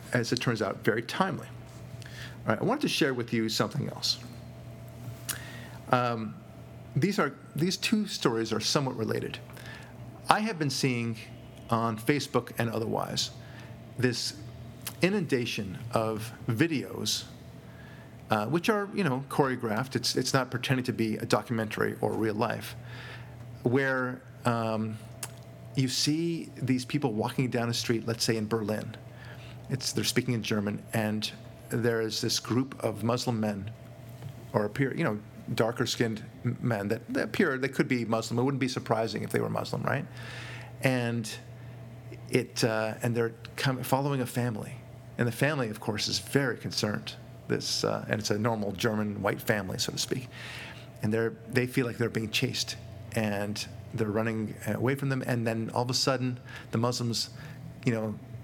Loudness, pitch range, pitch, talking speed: -30 LUFS, 115-130 Hz, 120 Hz, 160 wpm